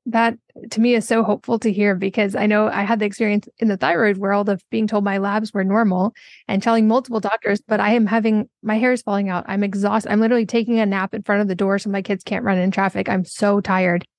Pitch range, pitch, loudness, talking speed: 200-225 Hz, 210 Hz, -19 LUFS, 260 wpm